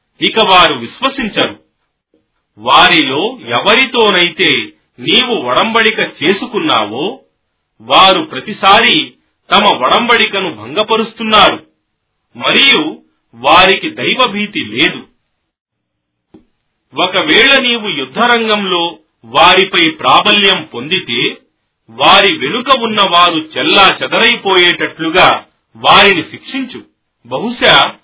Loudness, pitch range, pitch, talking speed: -9 LUFS, 185-240 Hz, 215 Hz, 70 wpm